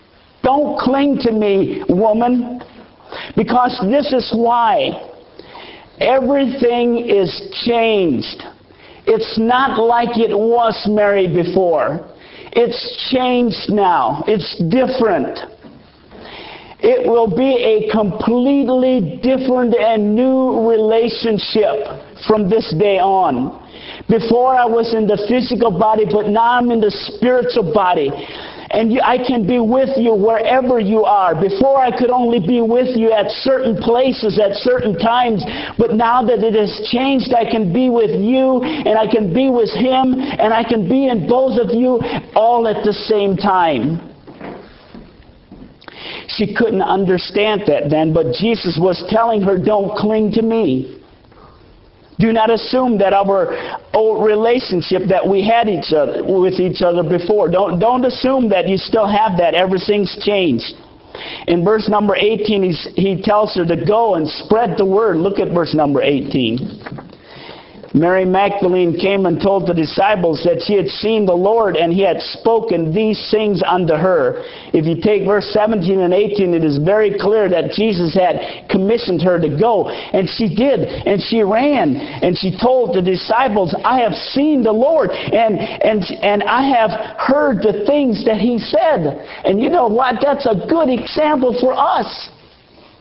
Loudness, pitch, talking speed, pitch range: -15 LUFS, 220 Hz, 155 wpm, 195-245 Hz